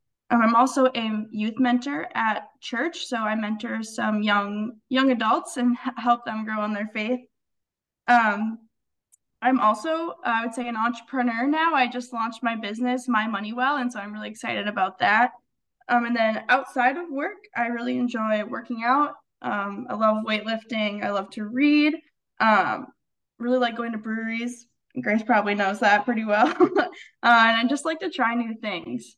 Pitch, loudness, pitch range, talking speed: 235 Hz, -24 LUFS, 215-255 Hz, 175 wpm